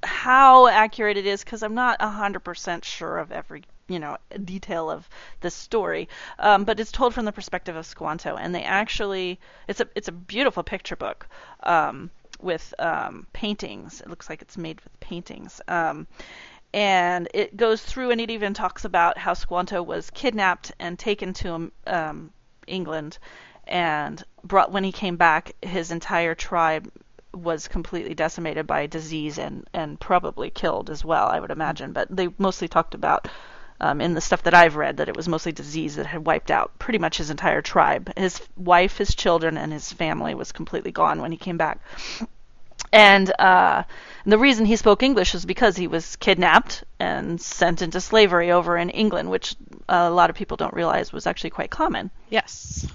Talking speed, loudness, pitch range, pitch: 180 wpm, -22 LUFS, 170-215 Hz, 185 Hz